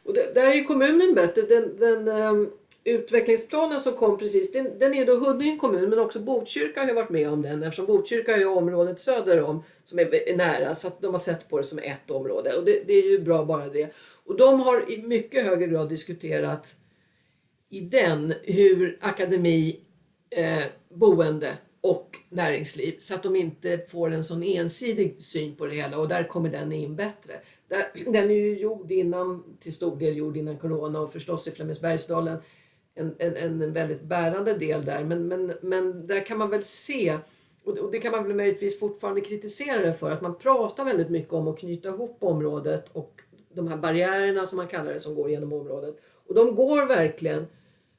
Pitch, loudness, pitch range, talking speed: 185 Hz, -25 LUFS, 160-230 Hz, 195 wpm